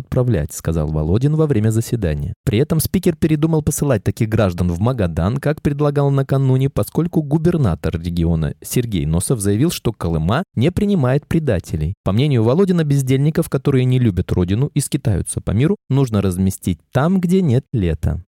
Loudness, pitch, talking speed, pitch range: -18 LUFS, 125 Hz, 155 wpm, 95-150 Hz